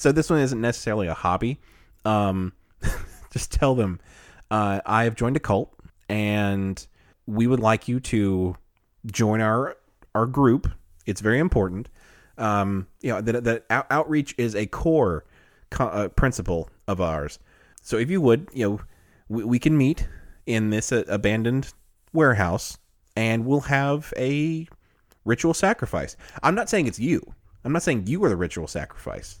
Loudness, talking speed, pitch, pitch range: -24 LUFS, 160 wpm, 110 Hz, 95-125 Hz